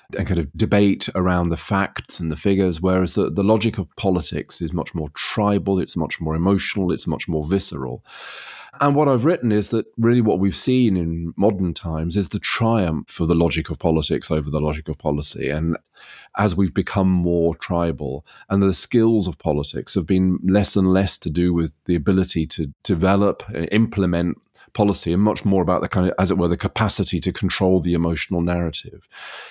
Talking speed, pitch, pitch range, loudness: 195 wpm, 90 Hz, 85-100 Hz, -20 LUFS